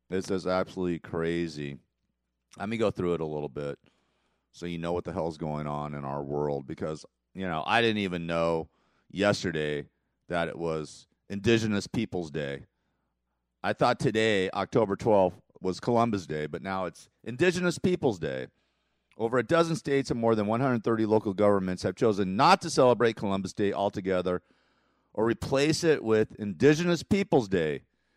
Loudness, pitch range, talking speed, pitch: -28 LUFS, 80-115 Hz, 160 wpm, 95 Hz